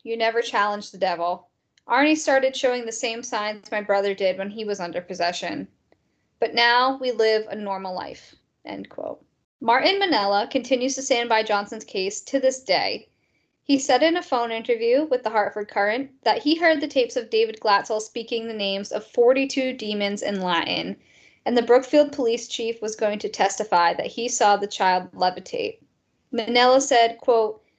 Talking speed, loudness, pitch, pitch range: 180 wpm, -22 LUFS, 230 Hz, 205-260 Hz